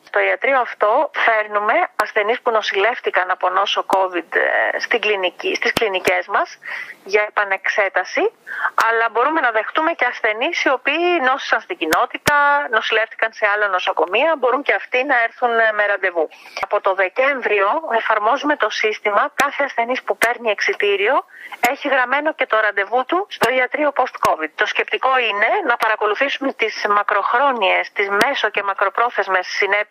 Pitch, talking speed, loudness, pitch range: 225 Hz, 140 wpm, -17 LUFS, 205-270 Hz